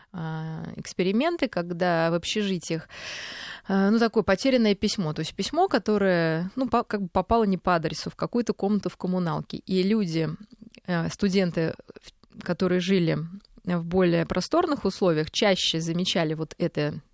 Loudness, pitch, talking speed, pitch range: -25 LUFS, 185 Hz, 130 wpm, 165-215 Hz